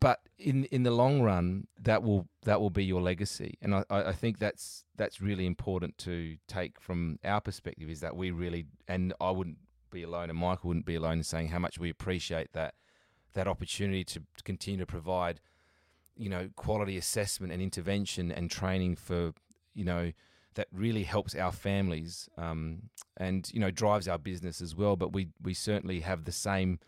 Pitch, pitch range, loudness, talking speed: 90 Hz, 85-100 Hz, -34 LUFS, 190 wpm